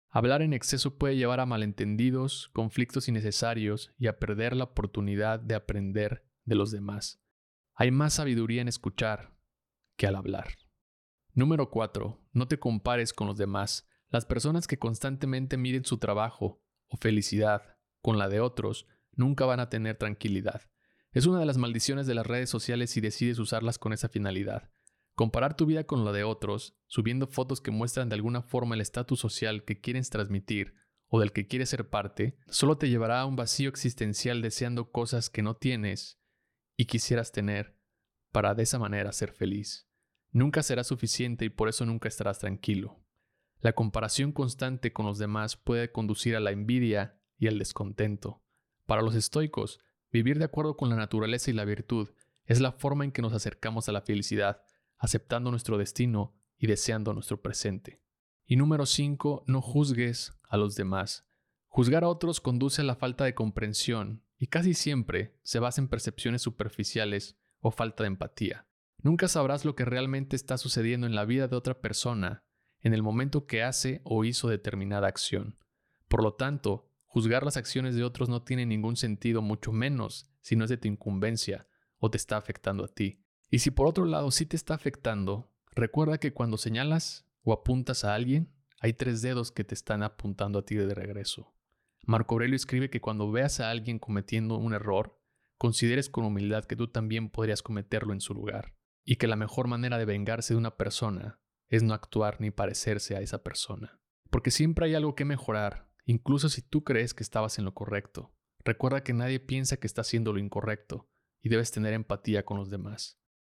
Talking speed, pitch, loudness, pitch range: 180 wpm, 115 Hz, -30 LUFS, 105-130 Hz